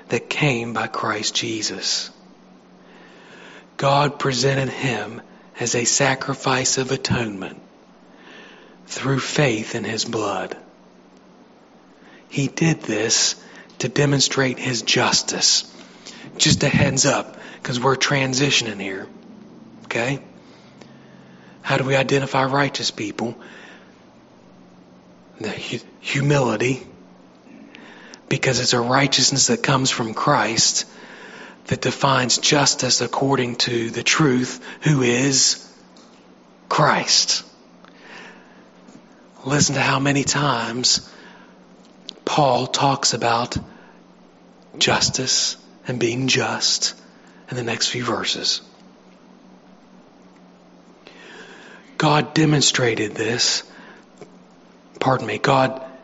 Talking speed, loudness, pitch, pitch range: 90 wpm, -19 LUFS, 130 Hz, 120-140 Hz